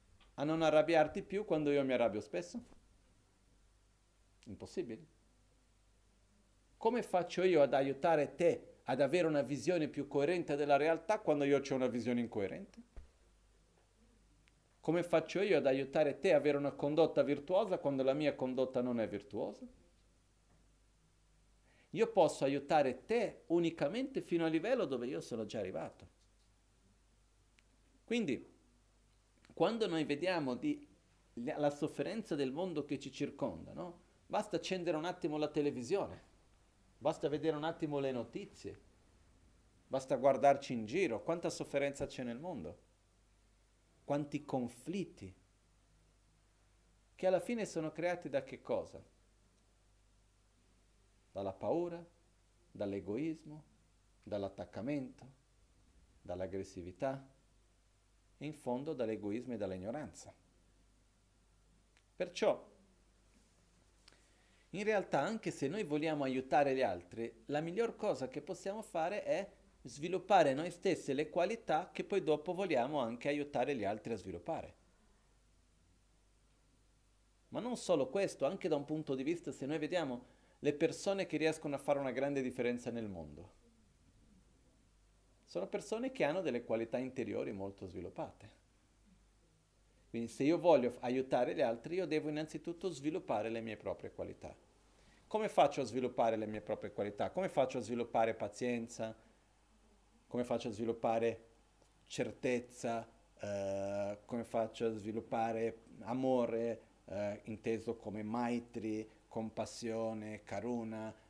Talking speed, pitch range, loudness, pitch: 120 wpm, 100-155 Hz, -37 LUFS, 125 Hz